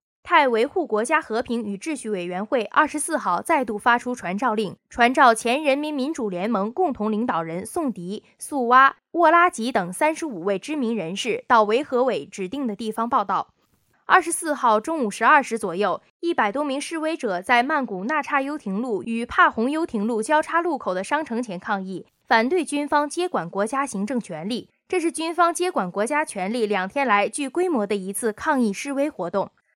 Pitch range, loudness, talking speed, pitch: 215-305 Hz, -22 LUFS, 295 characters per minute, 245 Hz